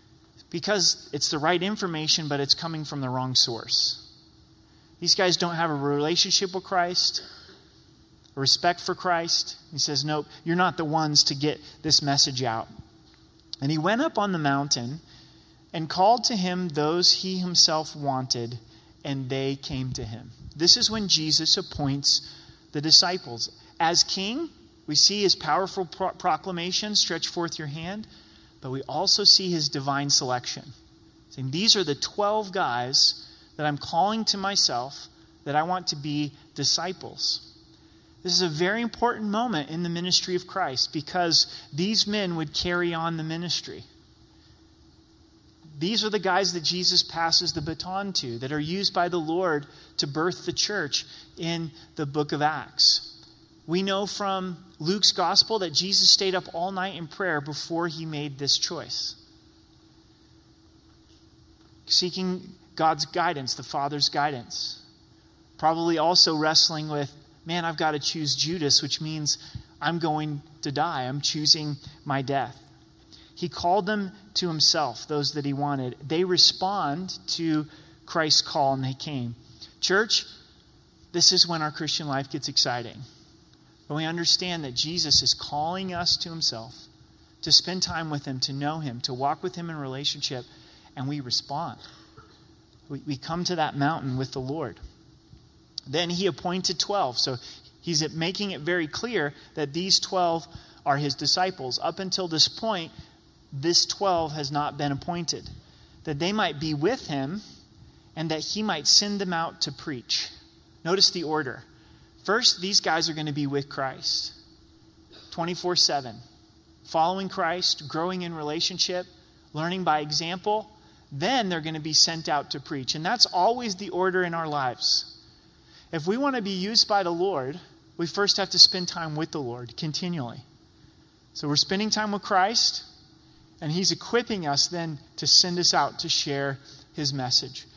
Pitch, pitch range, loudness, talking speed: 160 Hz, 145-180 Hz, -24 LUFS, 160 wpm